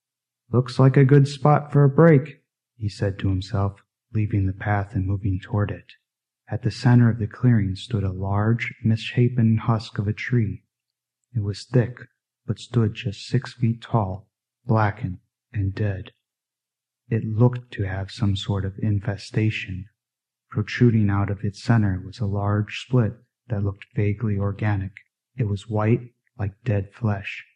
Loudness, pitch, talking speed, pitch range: -23 LUFS, 110 Hz, 155 wpm, 100-120 Hz